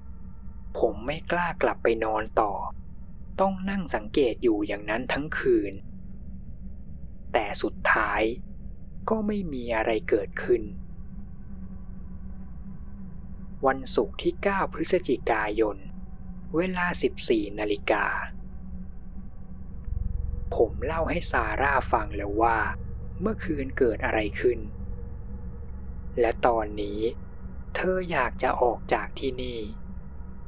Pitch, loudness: 105 Hz, -27 LUFS